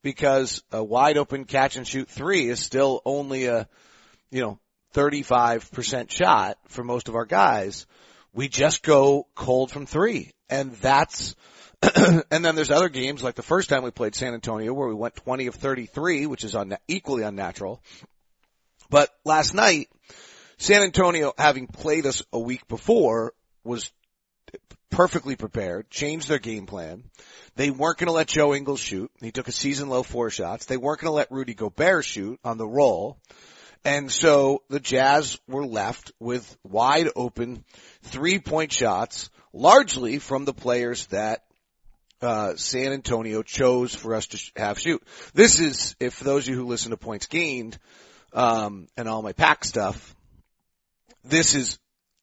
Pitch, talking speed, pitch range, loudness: 130 Hz, 165 wpm, 115-145 Hz, -23 LUFS